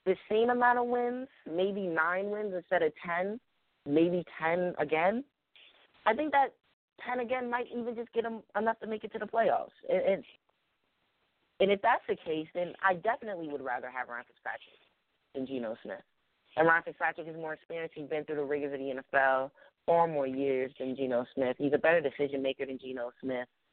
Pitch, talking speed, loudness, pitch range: 165 Hz, 190 wpm, -32 LUFS, 140-220 Hz